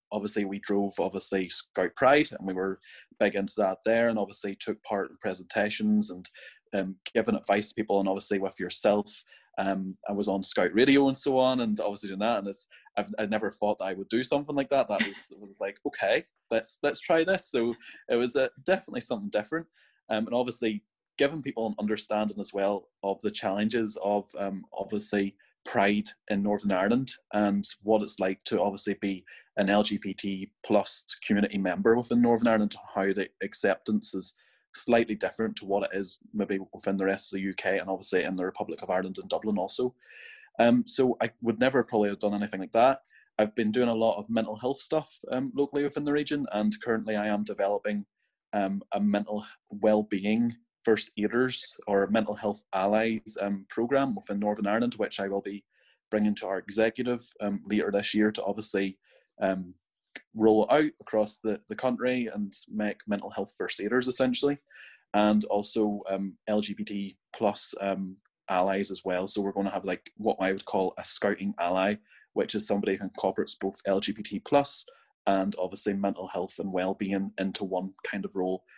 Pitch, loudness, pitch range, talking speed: 105 Hz, -29 LUFS, 100-115 Hz, 190 wpm